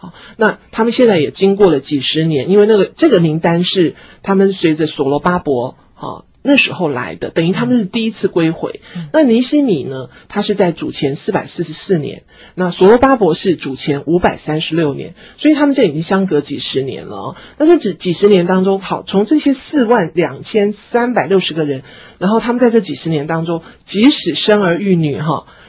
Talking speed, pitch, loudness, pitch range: 310 characters per minute, 190 Hz, -14 LUFS, 160-225 Hz